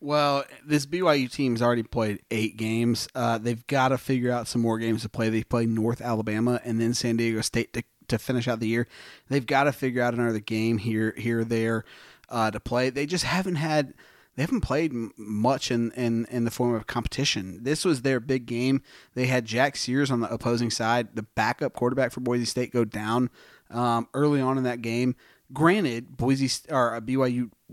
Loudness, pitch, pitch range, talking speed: -26 LUFS, 120 Hz, 115-130 Hz, 205 wpm